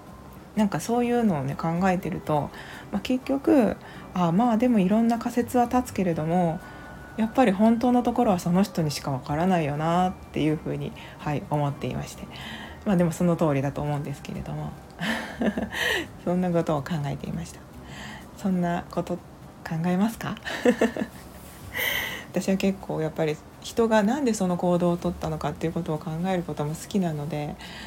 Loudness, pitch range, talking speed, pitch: -26 LUFS, 155-220 Hz, 360 characters per minute, 175 Hz